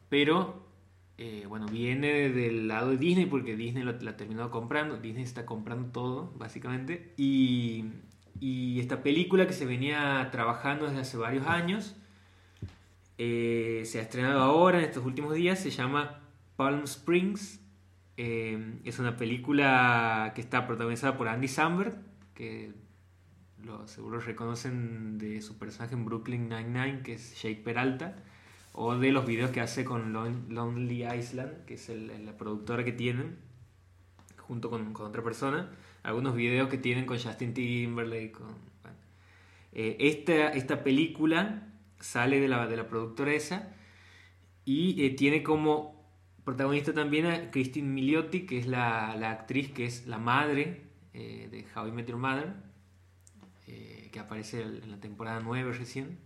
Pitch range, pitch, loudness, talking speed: 110-135 Hz, 120 Hz, -31 LUFS, 155 wpm